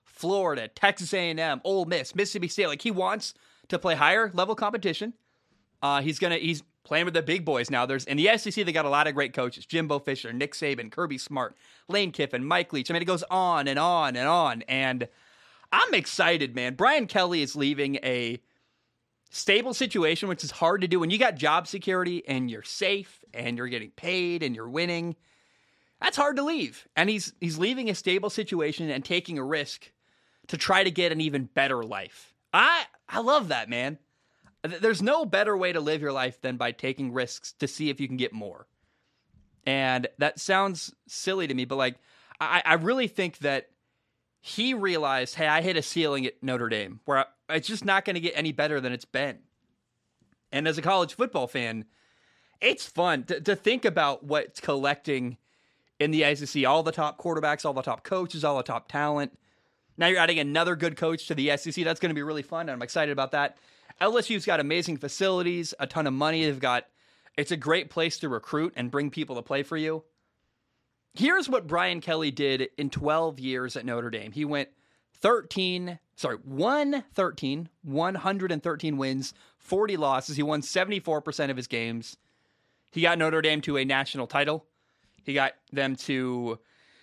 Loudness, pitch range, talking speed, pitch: -27 LUFS, 135-180 Hz, 190 wpm, 155 Hz